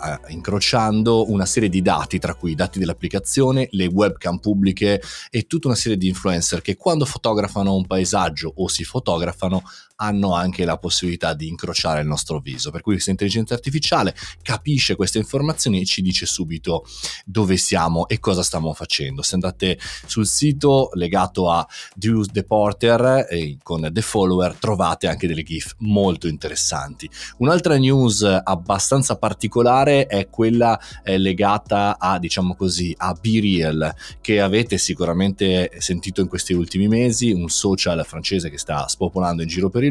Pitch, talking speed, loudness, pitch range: 95 Hz, 150 wpm, -20 LUFS, 85-110 Hz